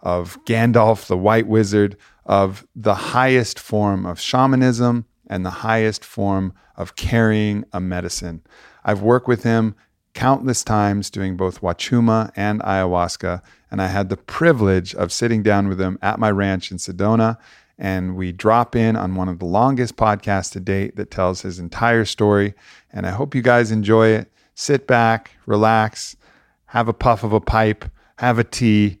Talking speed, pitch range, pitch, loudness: 170 wpm, 95-115 Hz, 105 Hz, -19 LUFS